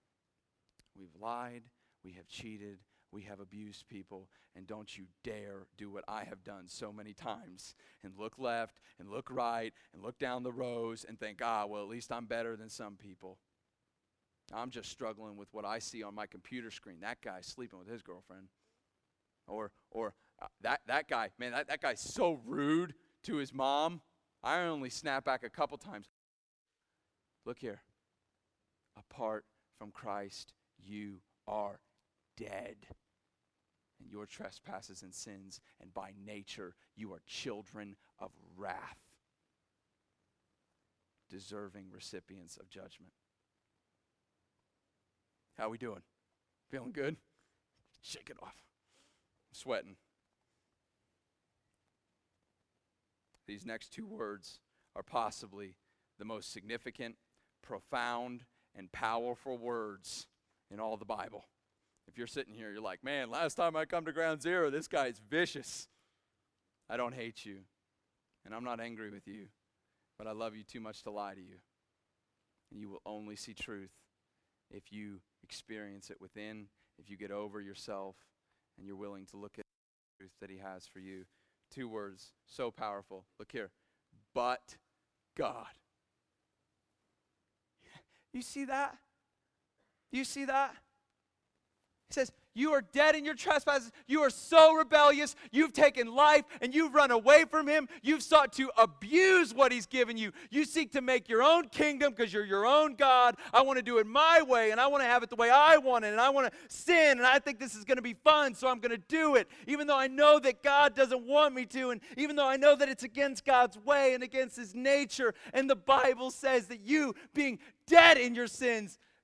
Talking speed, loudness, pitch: 165 wpm, -29 LUFS, 120 Hz